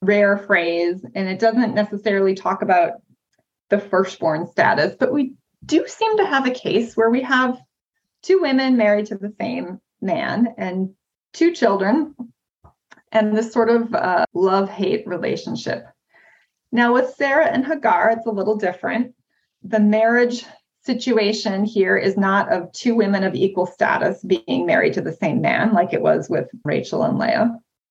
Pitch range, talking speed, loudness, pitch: 195-245 Hz, 160 wpm, -19 LUFS, 220 Hz